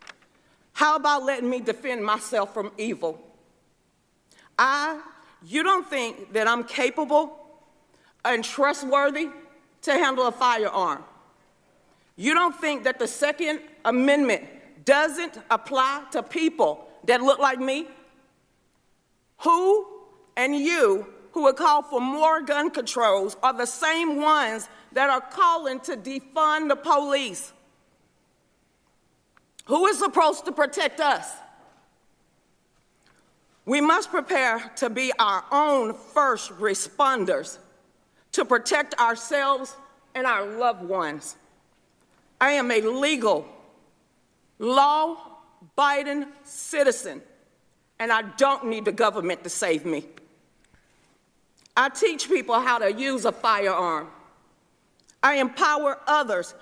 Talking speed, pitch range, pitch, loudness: 110 wpm, 235-300 Hz, 275 Hz, -23 LUFS